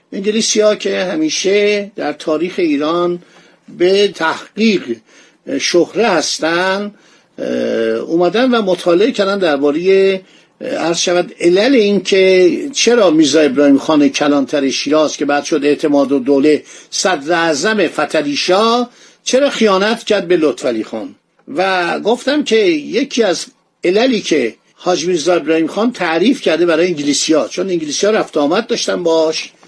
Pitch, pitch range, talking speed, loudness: 180 Hz, 160-215 Hz, 130 wpm, -14 LUFS